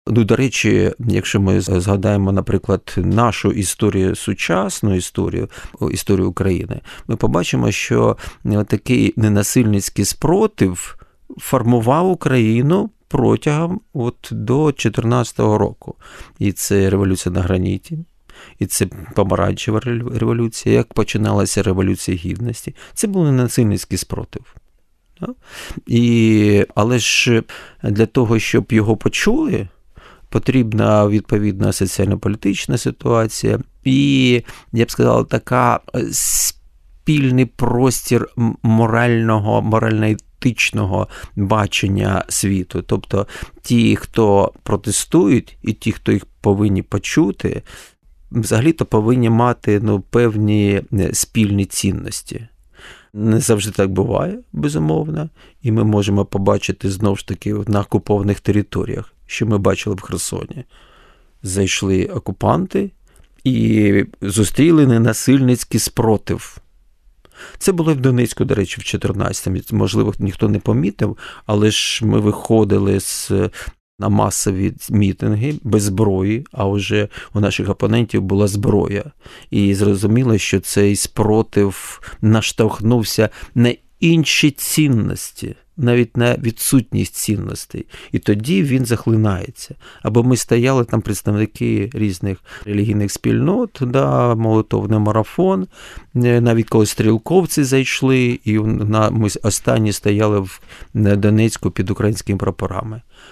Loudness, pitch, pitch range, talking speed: -17 LUFS, 110 Hz, 100-120 Hz, 105 wpm